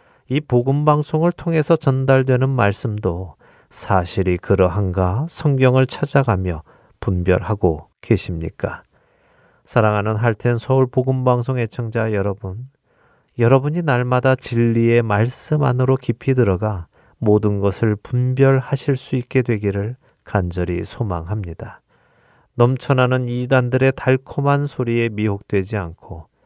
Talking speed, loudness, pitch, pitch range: 270 characters per minute, -19 LUFS, 120 Hz, 100-130 Hz